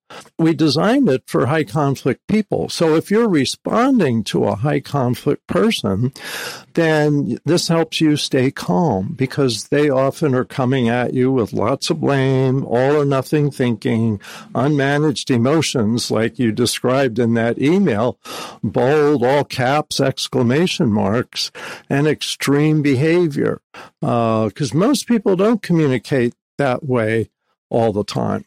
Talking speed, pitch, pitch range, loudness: 135 wpm, 140 Hz, 125-155 Hz, -17 LUFS